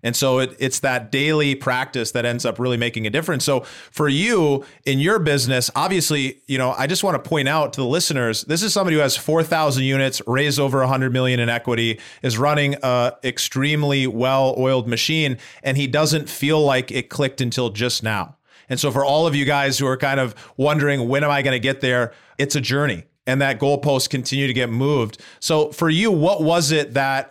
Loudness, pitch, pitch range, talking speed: -19 LUFS, 135 Hz, 130-145 Hz, 215 wpm